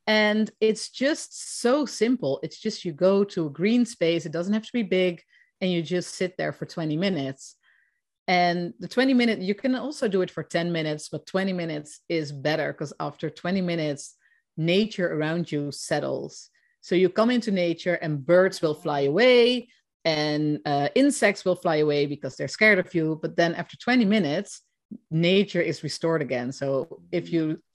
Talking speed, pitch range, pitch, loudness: 185 wpm, 160-215 Hz, 175 Hz, -25 LUFS